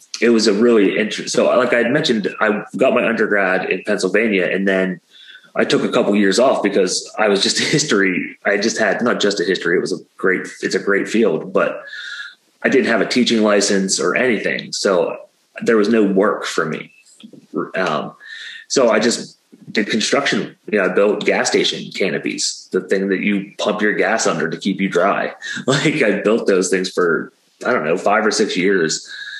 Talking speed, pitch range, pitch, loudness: 200 wpm, 95-120 Hz, 100 Hz, -17 LUFS